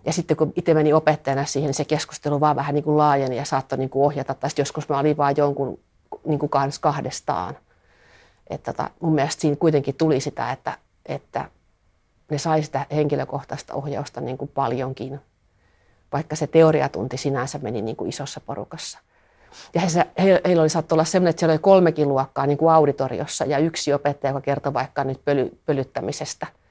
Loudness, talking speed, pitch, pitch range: -22 LUFS, 170 wpm, 145 Hz, 135-155 Hz